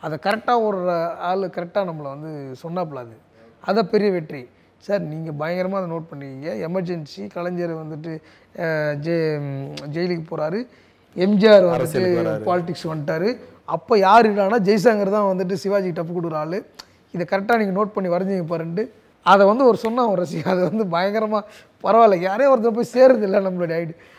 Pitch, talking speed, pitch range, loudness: 180 Hz, 145 wpm, 165-210 Hz, -20 LUFS